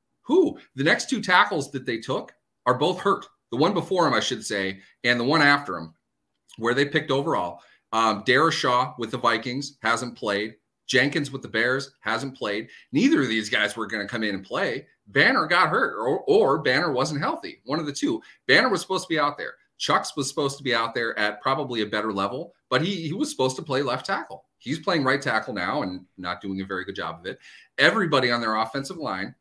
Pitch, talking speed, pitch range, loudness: 125 Hz, 225 wpm, 105-145 Hz, -24 LUFS